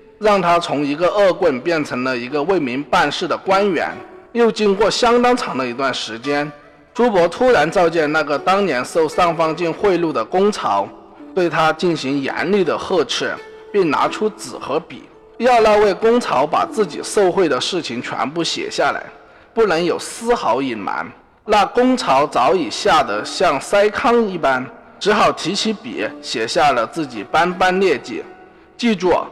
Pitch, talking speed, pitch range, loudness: 200 Hz, 240 characters per minute, 165-240 Hz, -17 LUFS